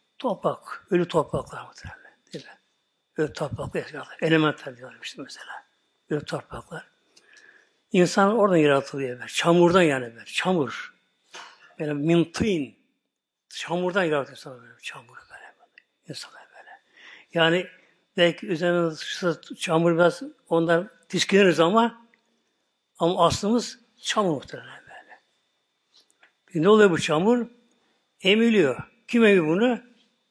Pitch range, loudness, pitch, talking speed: 160-230 Hz, -23 LUFS, 175 Hz, 110 wpm